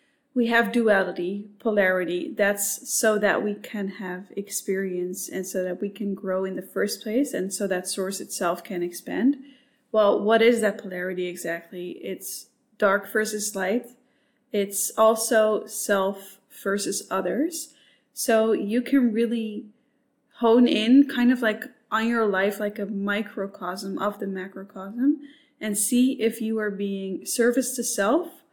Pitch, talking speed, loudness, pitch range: 215 Hz, 145 wpm, -24 LUFS, 195-245 Hz